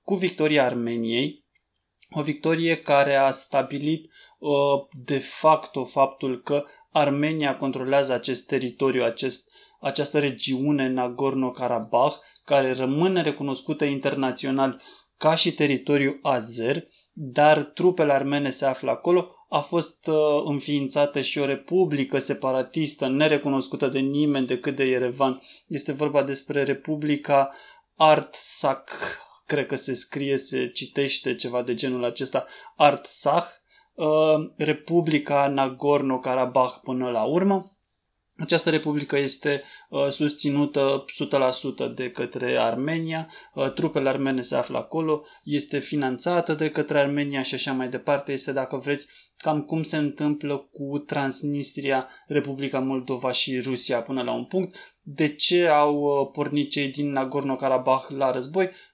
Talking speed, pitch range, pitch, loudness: 120 wpm, 135-150 Hz, 140 Hz, -24 LUFS